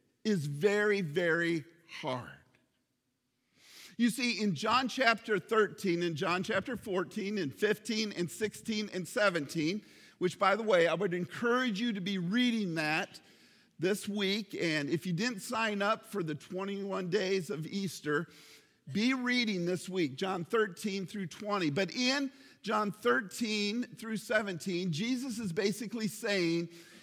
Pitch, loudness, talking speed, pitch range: 200 Hz, -33 LUFS, 140 wpm, 180-220 Hz